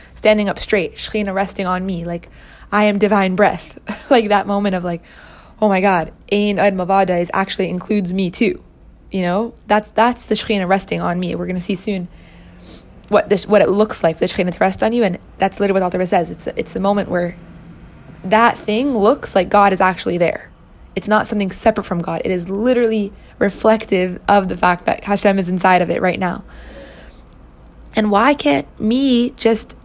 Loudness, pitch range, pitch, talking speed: -17 LUFS, 185-215 Hz, 200 Hz, 195 wpm